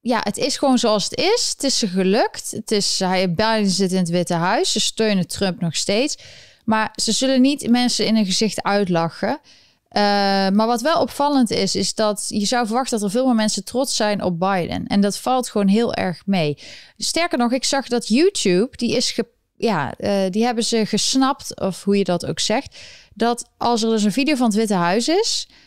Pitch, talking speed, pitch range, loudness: 220 Hz, 215 wpm, 200-245 Hz, -19 LUFS